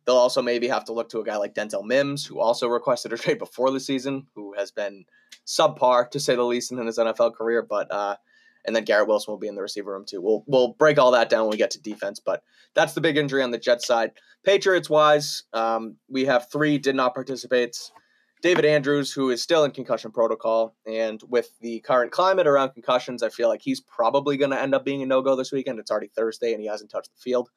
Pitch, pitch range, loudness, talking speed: 130 Hz, 115-145 Hz, -23 LUFS, 245 wpm